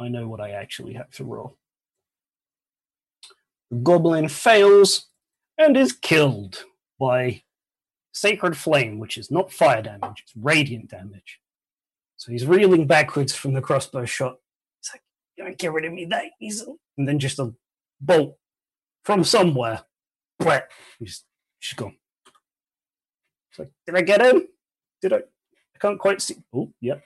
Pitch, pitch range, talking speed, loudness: 155 Hz, 125-195 Hz, 150 wpm, -20 LUFS